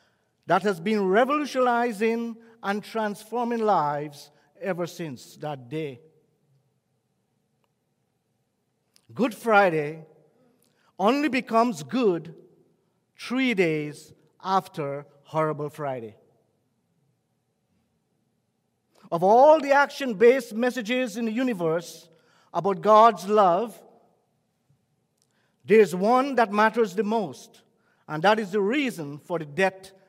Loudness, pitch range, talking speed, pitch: -23 LUFS, 155-230 Hz, 95 wpm, 200 Hz